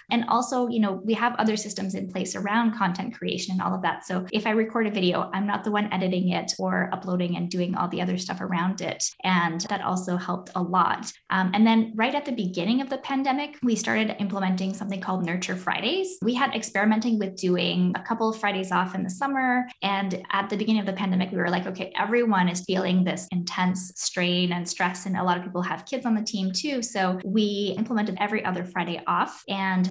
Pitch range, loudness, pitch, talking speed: 185-220 Hz, -26 LUFS, 195 Hz, 225 wpm